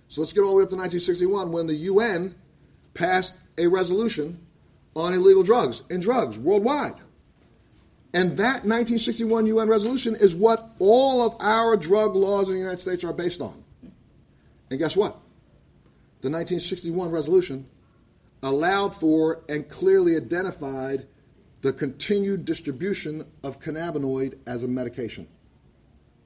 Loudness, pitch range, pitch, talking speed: -23 LUFS, 155-205 Hz, 180 Hz, 135 wpm